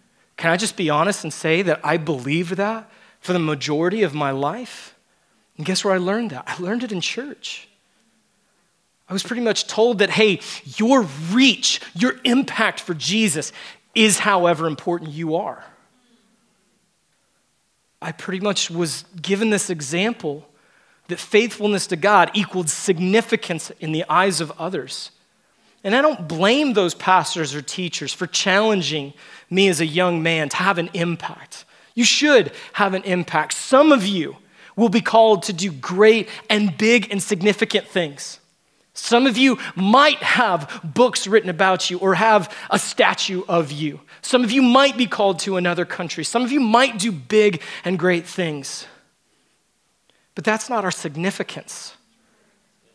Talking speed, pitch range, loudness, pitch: 160 wpm, 170-220 Hz, -19 LUFS, 195 Hz